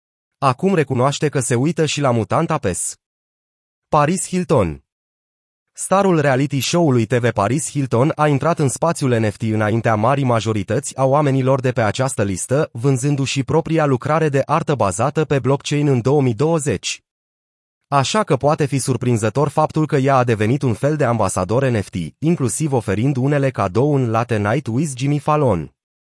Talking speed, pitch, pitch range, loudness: 150 wpm, 135 Hz, 115-150 Hz, -18 LUFS